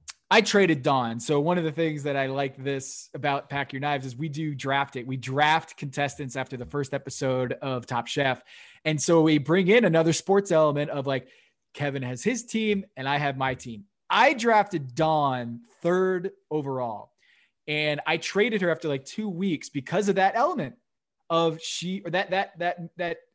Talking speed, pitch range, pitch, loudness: 195 wpm, 135-175 Hz, 150 Hz, -26 LUFS